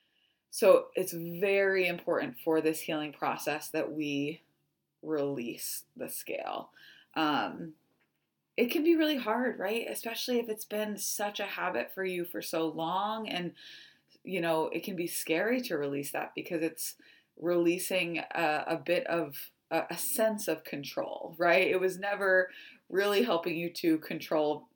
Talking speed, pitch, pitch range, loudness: 155 wpm, 175 Hz, 160-205 Hz, -31 LUFS